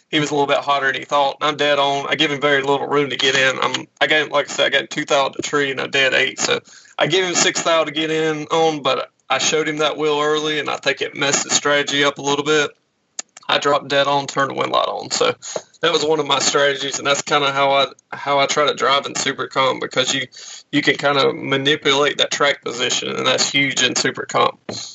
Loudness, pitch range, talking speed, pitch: -17 LUFS, 140-150 Hz, 260 wpm, 145 Hz